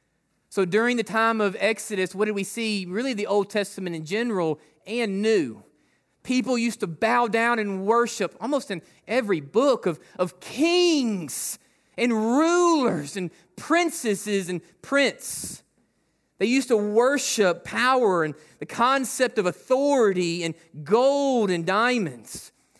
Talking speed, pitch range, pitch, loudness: 135 wpm, 185-245 Hz, 215 Hz, -24 LUFS